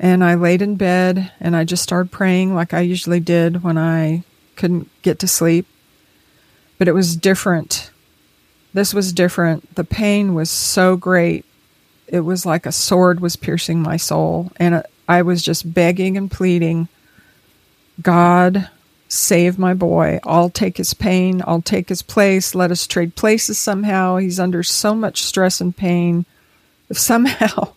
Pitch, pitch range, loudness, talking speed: 180 Hz, 170-185 Hz, -16 LUFS, 160 wpm